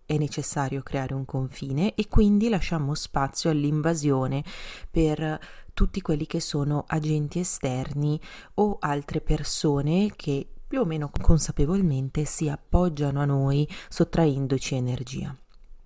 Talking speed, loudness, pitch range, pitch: 115 wpm, -26 LUFS, 140-165 Hz, 150 Hz